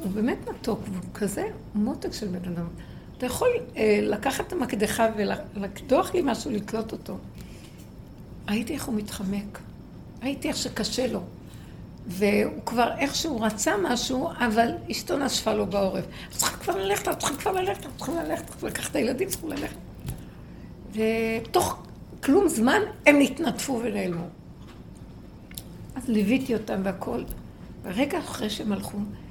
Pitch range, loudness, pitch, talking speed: 210-265 Hz, -27 LUFS, 225 Hz, 135 wpm